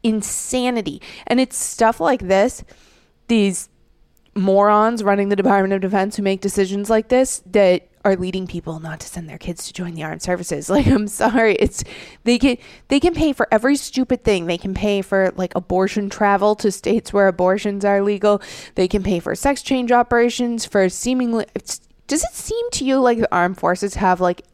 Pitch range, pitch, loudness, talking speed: 190-240 Hz, 205 Hz, -18 LUFS, 195 wpm